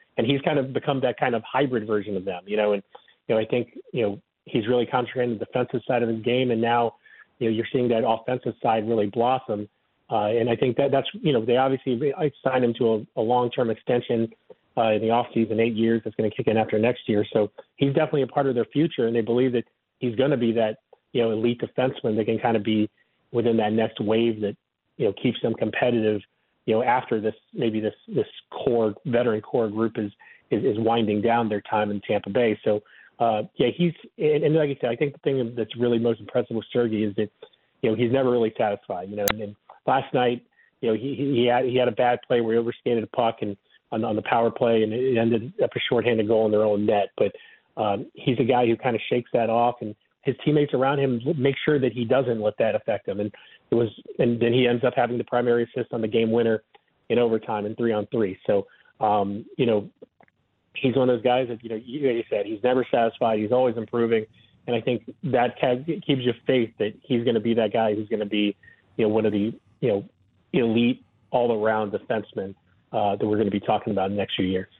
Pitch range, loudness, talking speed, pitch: 110-125 Hz, -24 LUFS, 240 wpm, 115 Hz